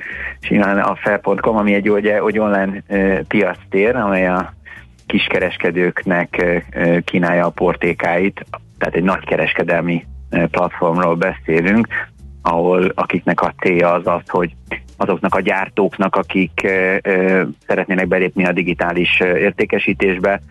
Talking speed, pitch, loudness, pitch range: 115 wpm, 90 Hz, -16 LUFS, 85-95 Hz